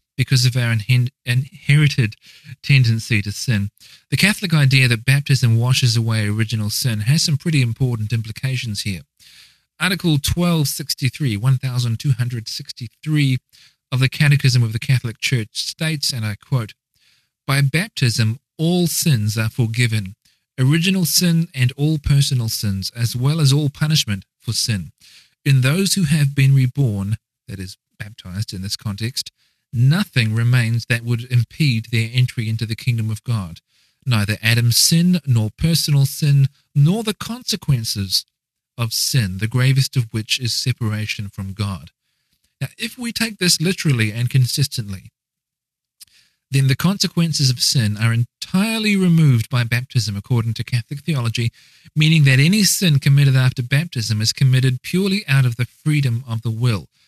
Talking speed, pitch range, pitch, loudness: 145 wpm, 115-145 Hz, 130 Hz, -18 LUFS